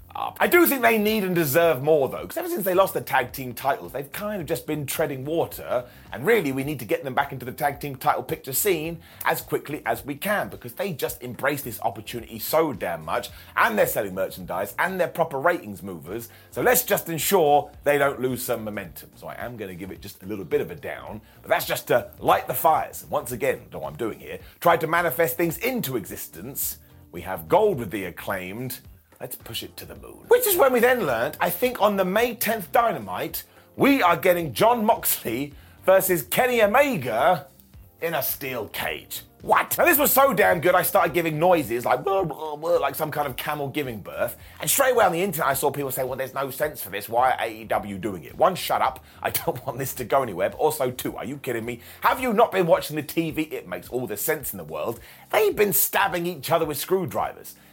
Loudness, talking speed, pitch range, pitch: -23 LUFS, 235 wpm, 130-190 Hz, 155 Hz